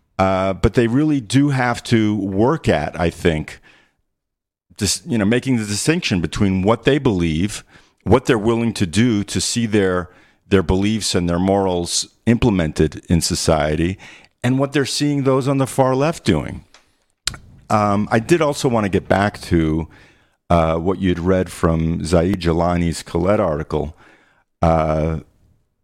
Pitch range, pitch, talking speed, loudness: 85-120 Hz, 100 Hz, 155 wpm, -18 LUFS